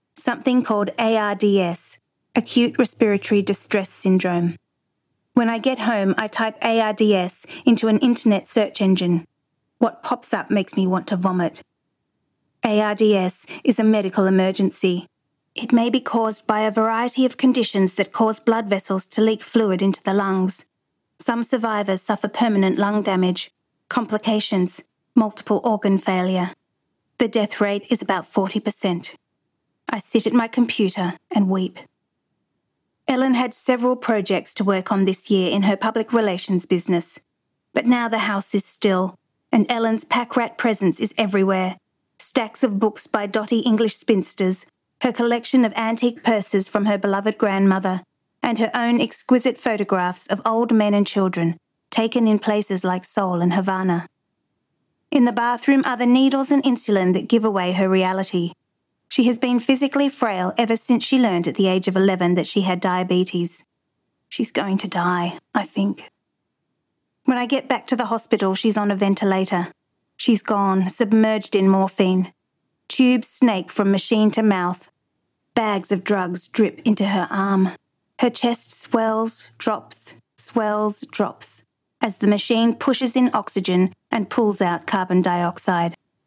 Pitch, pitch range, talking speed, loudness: 210 Hz, 190-230 Hz, 150 wpm, -20 LUFS